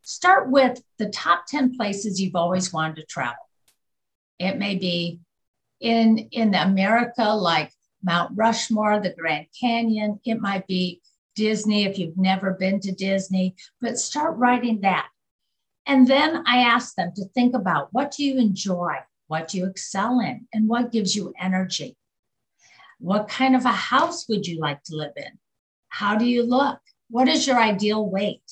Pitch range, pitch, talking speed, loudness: 185-240 Hz, 210 Hz, 165 wpm, -22 LUFS